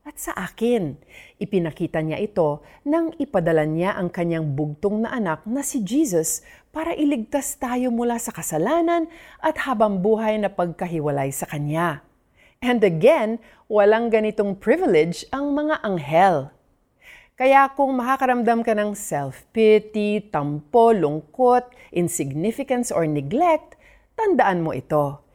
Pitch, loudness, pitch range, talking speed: 215 Hz, -21 LUFS, 165-260 Hz, 125 wpm